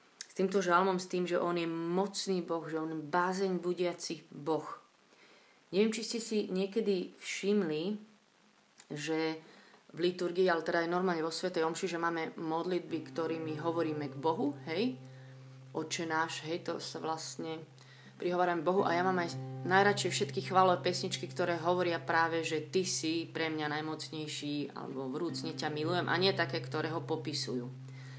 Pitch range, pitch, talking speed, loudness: 155-180 Hz, 165 Hz, 160 wpm, -34 LUFS